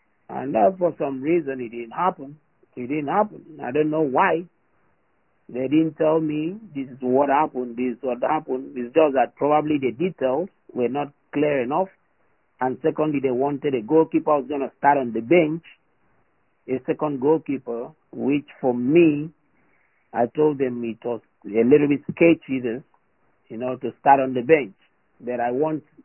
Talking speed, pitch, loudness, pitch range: 175 wpm, 145 Hz, -22 LUFS, 130-160 Hz